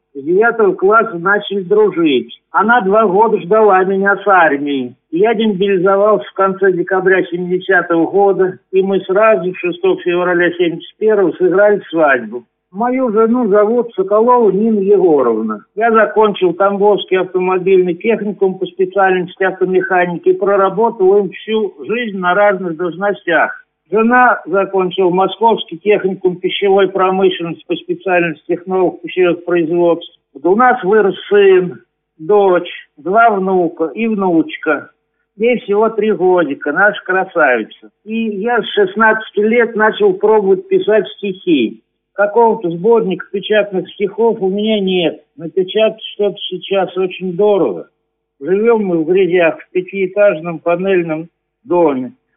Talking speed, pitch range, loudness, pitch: 120 wpm, 180-220 Hz, -13 LUFS, 195 Hz